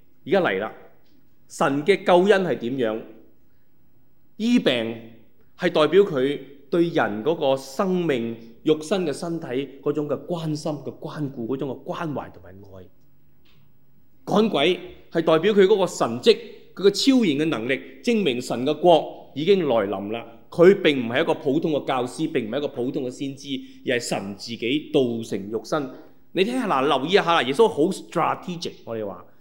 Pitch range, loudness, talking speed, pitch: 120-175 Hz, -22 LUFS, 255 characters per minute, 150 Hz